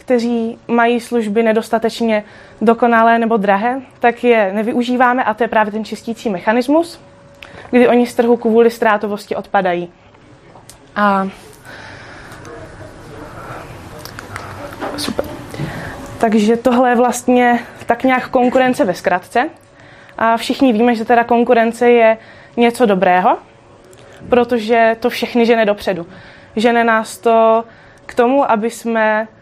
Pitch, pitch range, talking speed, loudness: 235 Hz, 220-245 Hz, 115 wpm, -14 LUFS